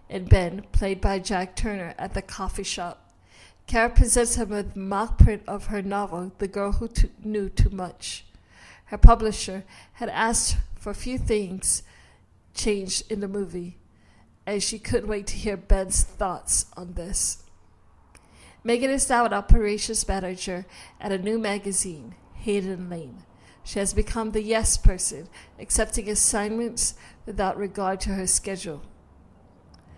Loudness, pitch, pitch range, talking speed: -25 LUFS, 195 Hz, 170-215 Hz, 150 wpm